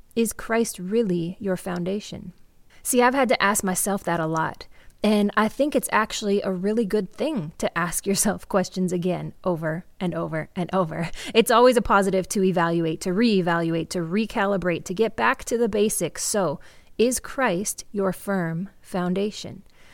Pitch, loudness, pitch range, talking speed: 195 Hz, -23 LUFS, 175-215 Hz, 165 wpm